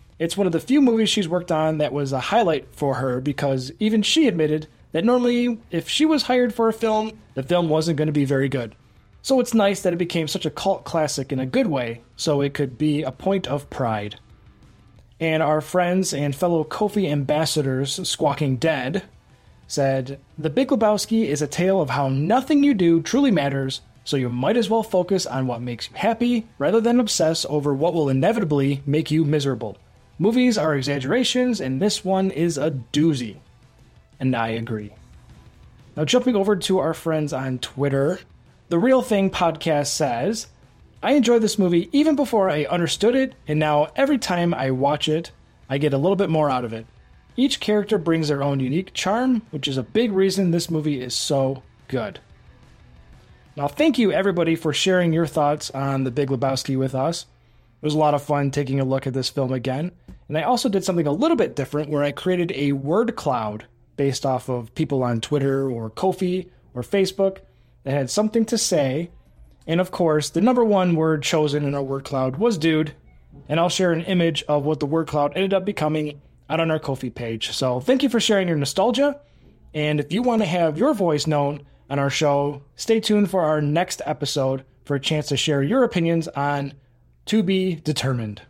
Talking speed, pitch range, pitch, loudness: 200 wpm, 135-190 Hz, 155 Hz, -21 LUFS